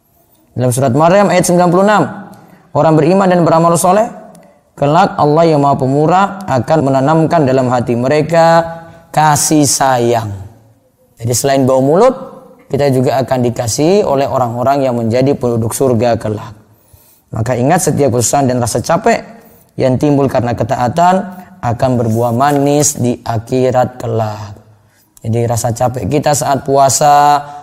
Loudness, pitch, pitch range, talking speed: -12 LUFS, 135 Hz, 120-165 Hz, 130 wpm